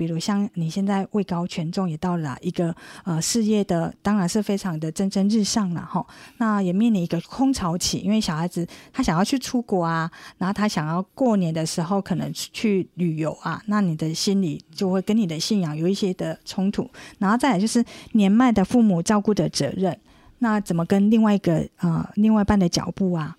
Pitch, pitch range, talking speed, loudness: 195 Hz, 170-210 Hz, 305 characters per minute, -23 LUFS